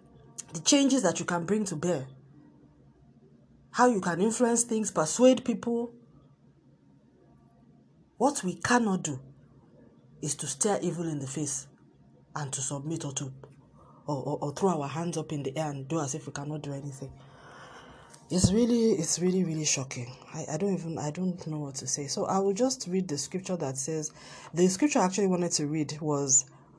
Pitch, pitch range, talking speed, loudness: 160 Hz, 140-190 Hz, 180 wpm, -29 LUFS